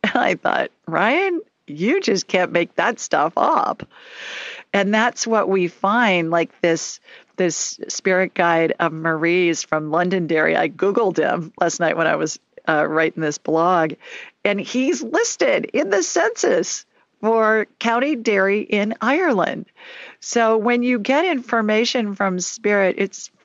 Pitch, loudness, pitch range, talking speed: 200 Hz, -19 LUFS, 170-240 Hz, 145 wpm